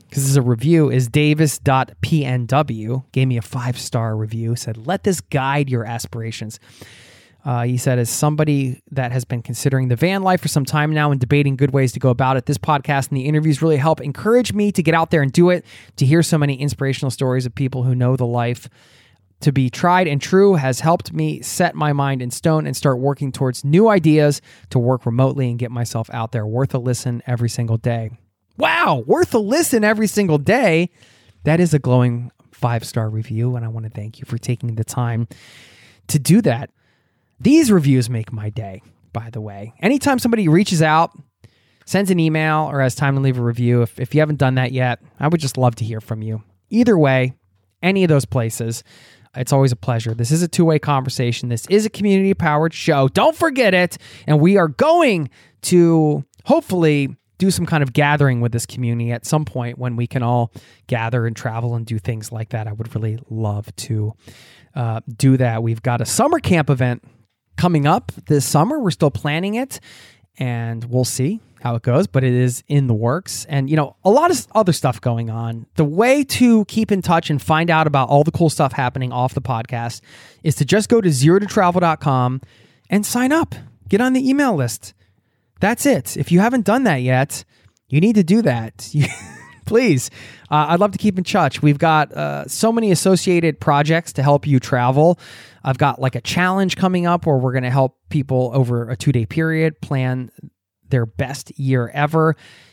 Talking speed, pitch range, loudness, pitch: 205 wpm, 120-160 Hz, -18 LUFS, 135 Hz